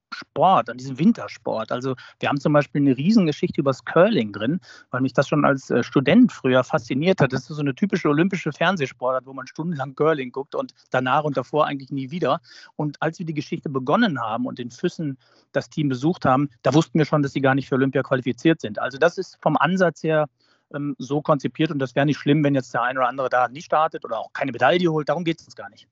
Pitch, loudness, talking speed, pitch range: 145 Hz, -22 LUFS, 240 wpm, 135-160 Hz